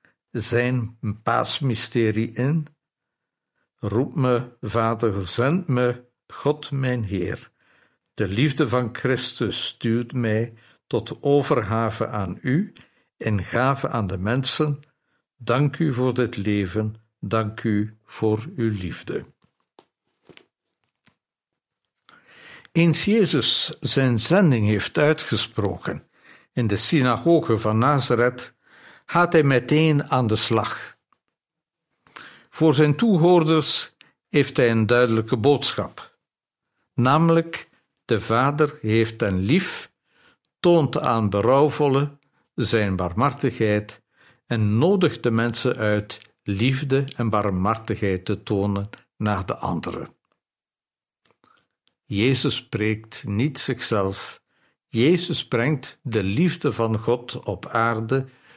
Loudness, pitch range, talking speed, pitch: -22 LUFS, 110-145 Hz, 100 wpm, 120 Hz